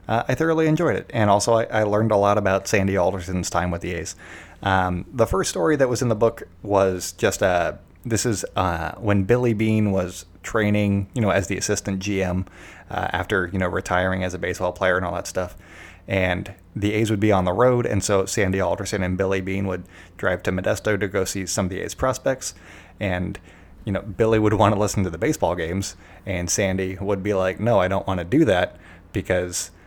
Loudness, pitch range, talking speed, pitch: -22 LUFS, 90-105 Hz, 225 wpm, 95 Hz